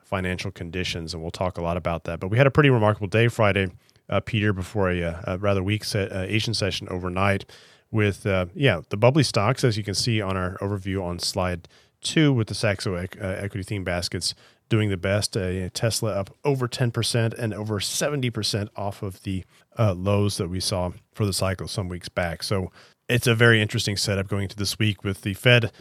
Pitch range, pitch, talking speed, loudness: 95-115 Hz, 100 Hz, 210 wpm, -24 LUFS